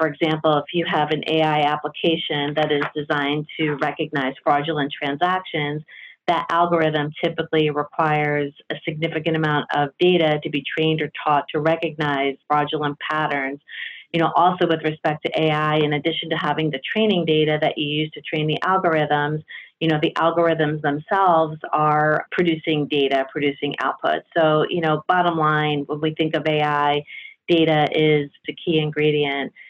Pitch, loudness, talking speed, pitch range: 155 Hz, -21 LUFS, 160 wpm, 150-160 Hz